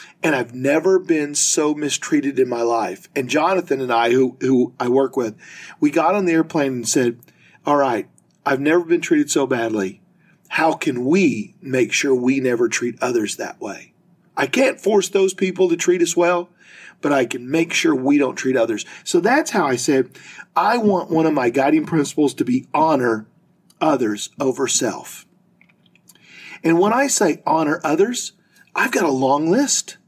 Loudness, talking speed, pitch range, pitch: -19 LUFS, 180 wpm, 135-200 Hz, 165 Hz